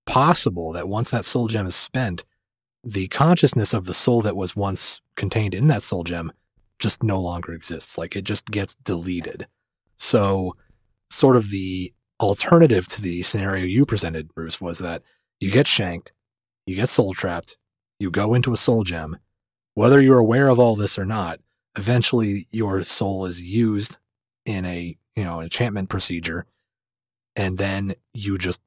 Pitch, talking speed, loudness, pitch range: 100 Hz, 165 wpm, -21 LUFS, 90-115 Hz